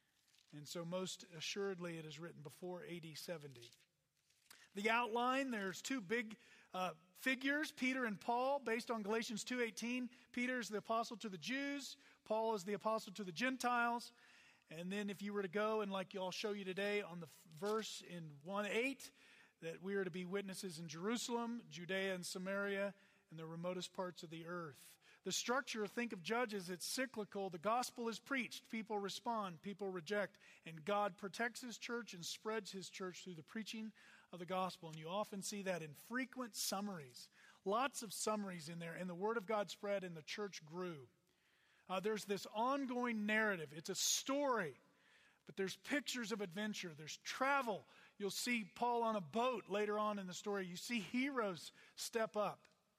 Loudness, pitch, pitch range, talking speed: -43 LUFS, 205 Hz, 185-230 Hz, 180 wpm